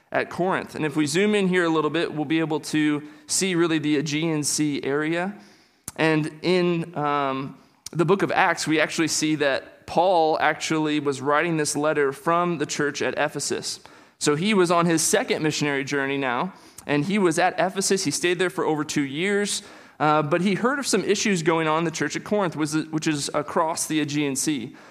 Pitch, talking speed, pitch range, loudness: 155 Hz, 200 wpm, 150-175 Hz, -23 LUFS